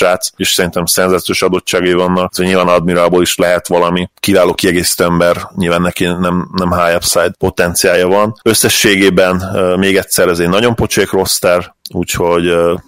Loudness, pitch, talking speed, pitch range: -11 LUFS, 90 Hz, 155 wpm, 85-90 Hz